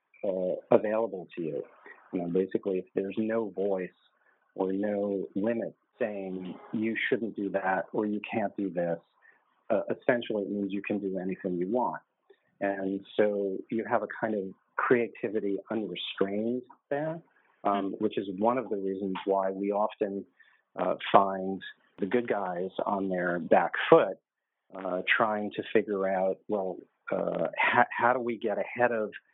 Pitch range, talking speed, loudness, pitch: 95-110 Hz, 155 wpm, -30 LUFS, 100 Hz